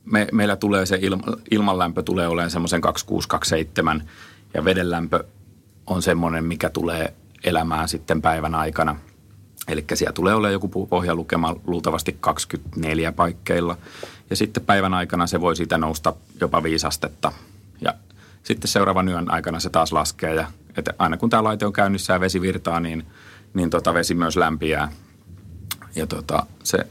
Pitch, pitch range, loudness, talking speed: 90 Hz, 80-100 Hz, -22 LUFS, 150 wpm